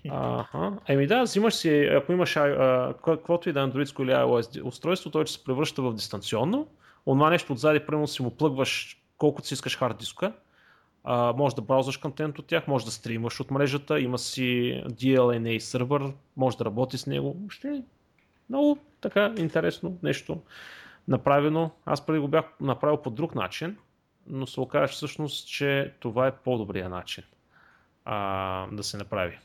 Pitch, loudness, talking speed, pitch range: 140 Hz, -27 LUFS, 165 wpm, 125-155 Hz